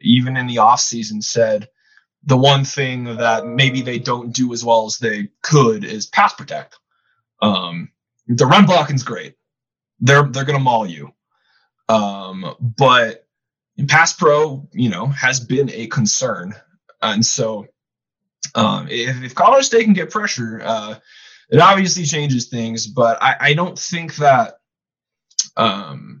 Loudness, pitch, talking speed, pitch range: -16 LUFS, 130 Hz, 145 wpm, 115-150 Hz